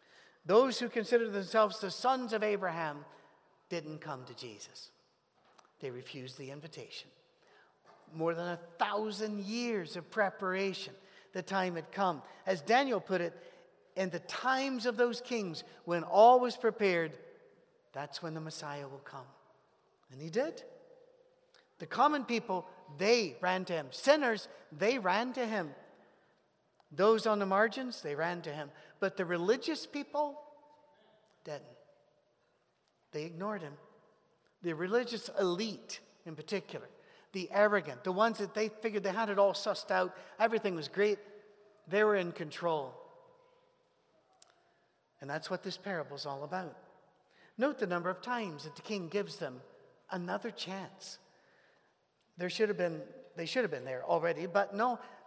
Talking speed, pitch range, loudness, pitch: 145 wpm, 170-235 Hz, -34 LUFS, 200 Hz